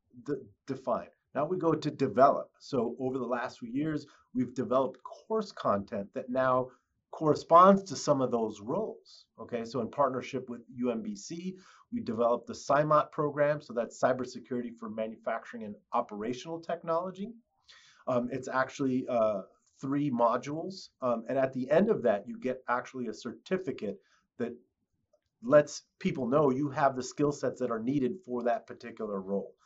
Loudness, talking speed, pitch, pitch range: -31 LUFS, 160 wpm, 130 Hz, 120-165 Hz